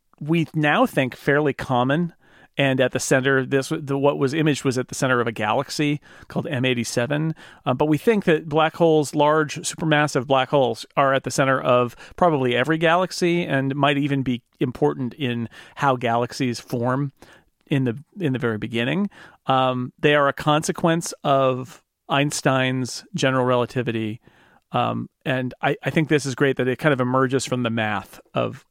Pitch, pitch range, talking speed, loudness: 135 Hz, 125-150 Hz, 175 wpm, -22 LUFS